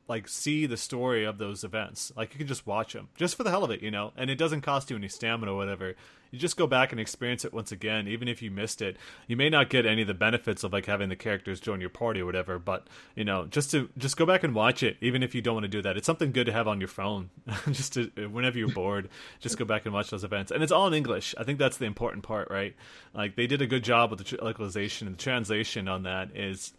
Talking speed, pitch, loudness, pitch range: 290 wpm, 110 Hz, -29 LUFS, 100-125 Hz